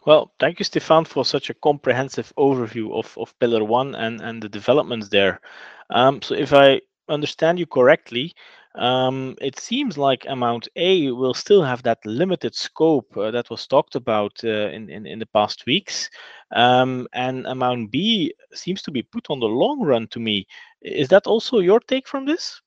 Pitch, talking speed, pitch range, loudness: 130 Hz, 185 wpm, 120-170 Hz, -20 LUFS